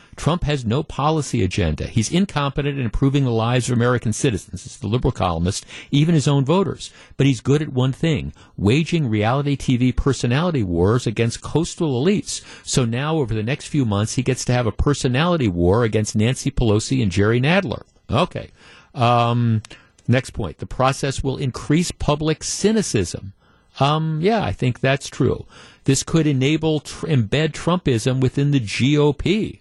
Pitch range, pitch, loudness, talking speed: 115-145 Hz, 130 Hz, -20 LUFS, 165 wpm